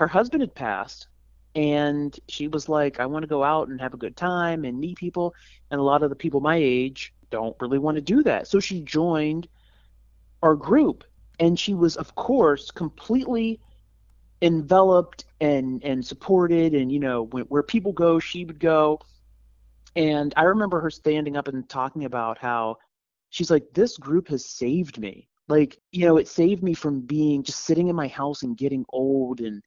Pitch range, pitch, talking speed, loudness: 130-170 Hz, 150 Hz, 190 wpm, -23 LUFS